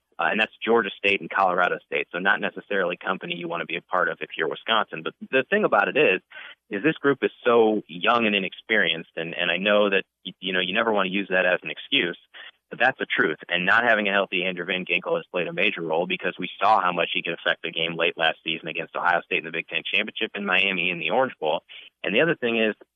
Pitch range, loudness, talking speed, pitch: 90-115 Hz, -23 LUFS, 265 wpm, 100 Hz